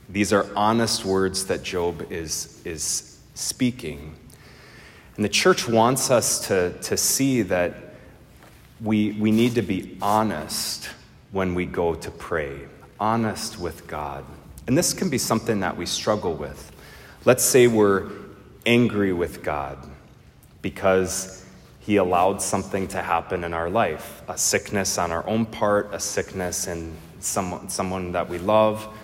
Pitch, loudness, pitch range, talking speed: 100 Hz, -23 LUFS, 90-110 Hz, 145 wpm